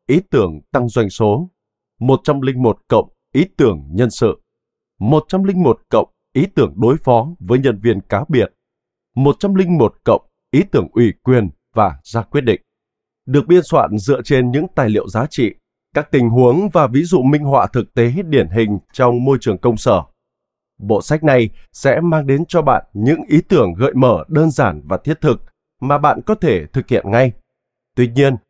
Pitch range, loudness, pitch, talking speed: 115-155 Hz, -15 LUFS, 130 Hz, 180 wpm